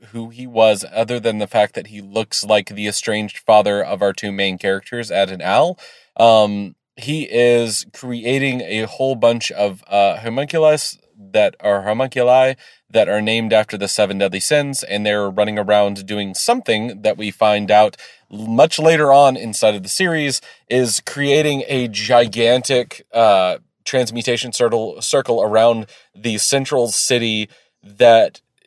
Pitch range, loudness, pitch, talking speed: 105-125 Hz, -16 LUFS, 115 Hz, 155 wpm